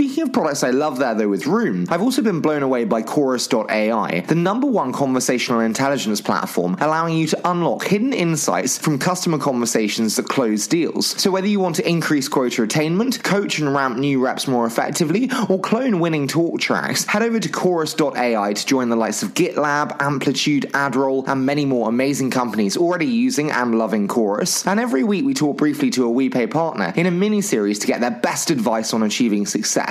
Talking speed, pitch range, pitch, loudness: 195 wpm, 125-175 Hz, 145 Hz, -19 LUFS